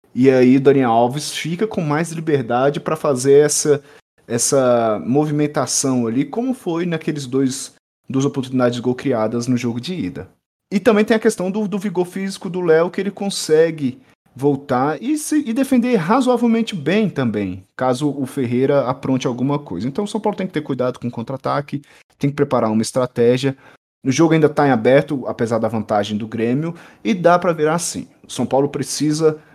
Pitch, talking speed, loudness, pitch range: 145 Hz, 185 wpm, -18 LUFS, 130-175 Hz